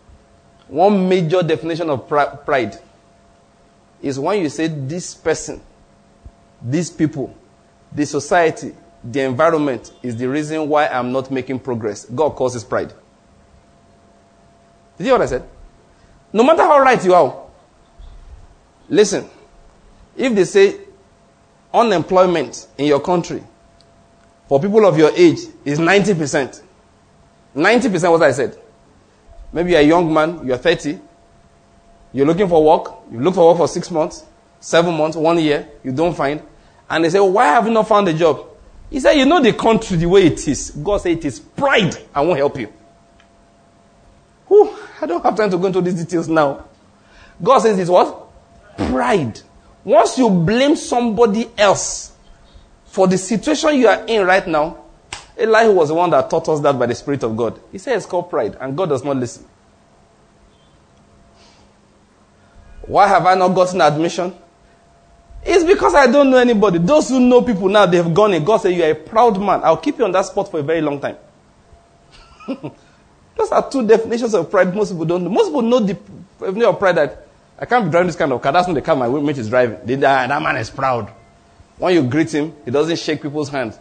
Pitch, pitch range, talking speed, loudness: 165 Hz, 140-210 Hz, 185 wpm, -16 LUFS